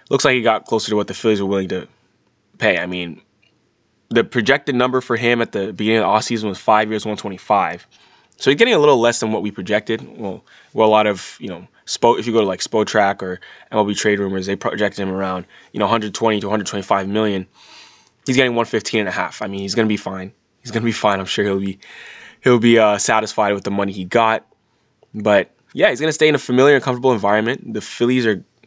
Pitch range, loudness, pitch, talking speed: 100-115 Hz, -18 LUFS, 105 Hz, 240 wpm